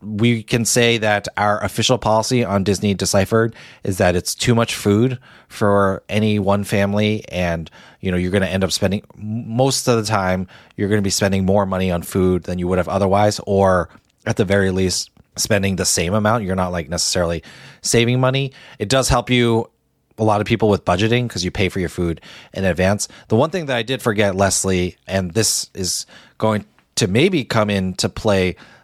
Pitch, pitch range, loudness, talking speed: 100 Hz, 95-115 Hz, -18 LUFS, 200 wpm